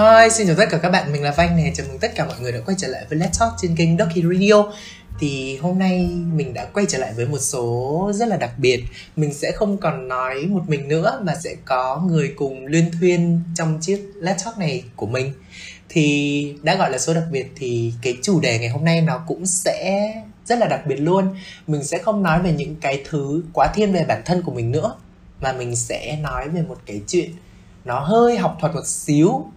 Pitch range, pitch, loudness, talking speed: 135-185 Hz, 160 Hz, -20 LUFS, 235 wpm